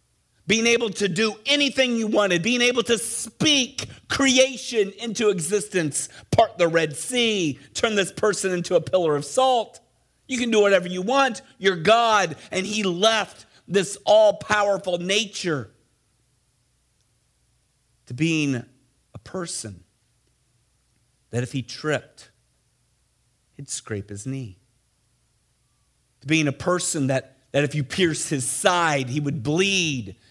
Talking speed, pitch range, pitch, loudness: 130 wpm, 135-215 Hz, 175 Hz, -22 LUFS